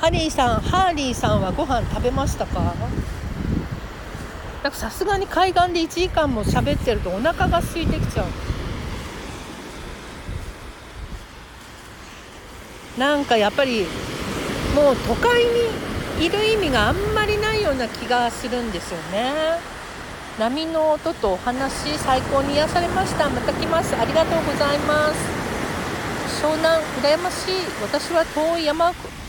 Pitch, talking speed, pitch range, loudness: 315 Hz, 260 characters per minute, 280-355 Hz, -21 LUFS